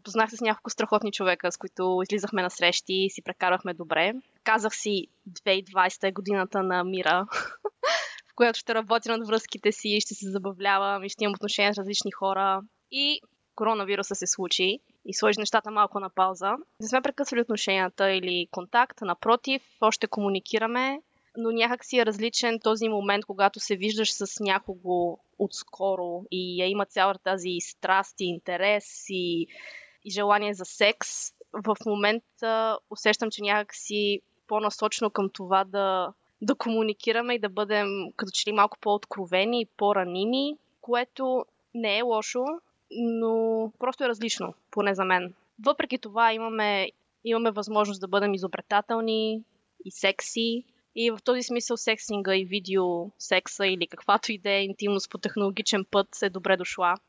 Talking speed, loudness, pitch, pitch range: 155 wpm, -27 LUFS, 205 Hz, 190-225 Hz